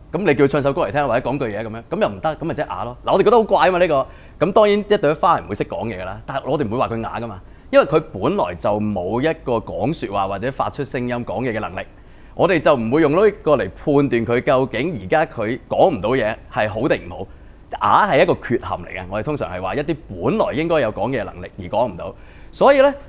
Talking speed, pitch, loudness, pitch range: 365 characters per minute, 130 Hz, -19 LUFS, 105-160 Hz